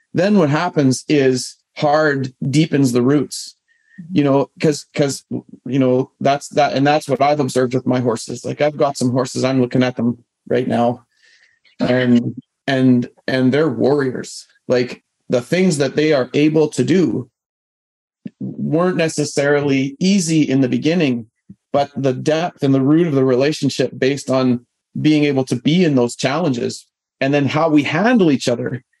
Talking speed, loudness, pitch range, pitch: 165 wpm, -17 LUFS, 130-155 Hz, 140 Hz